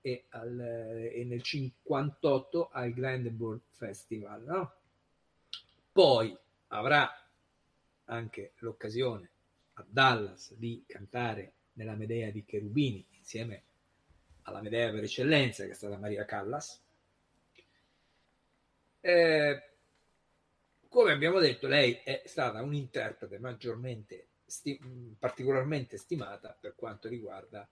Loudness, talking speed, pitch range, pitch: -32 LUFS, 100 wpm, 105-130 Hz, 115 Hz